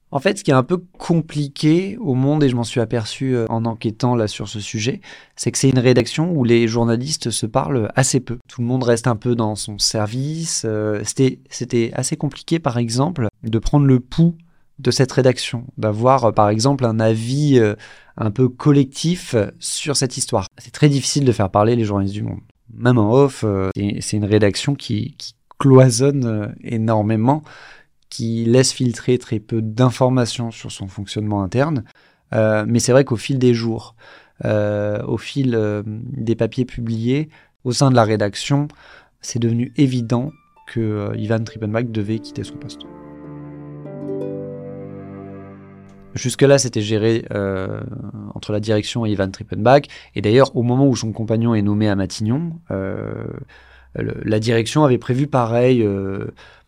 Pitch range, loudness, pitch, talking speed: 110-135 Hz, -18 LUFS, 120 Hz, 165 wpm